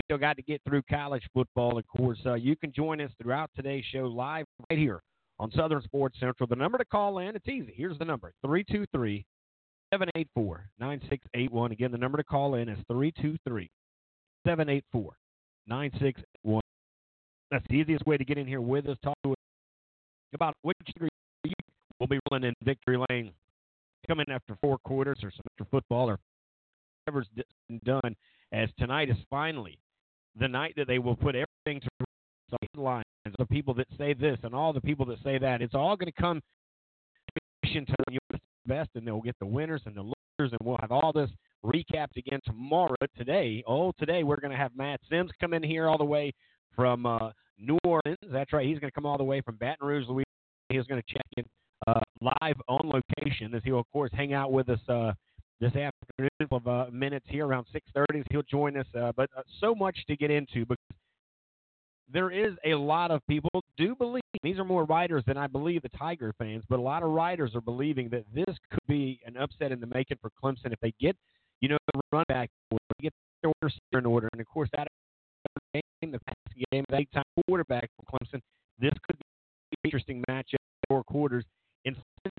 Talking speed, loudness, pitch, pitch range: 200 wpm, -31 LUFS, 135 Hz, 120-150 Hz